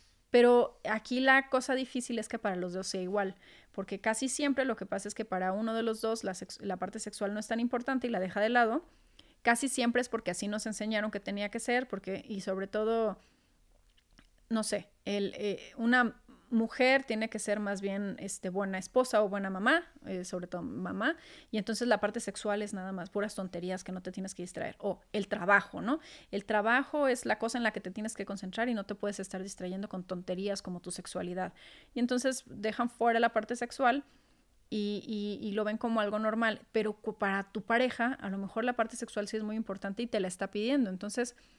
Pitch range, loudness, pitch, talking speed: 195-240 Hz, -33 LUFS, 215 Hz, 220 wpm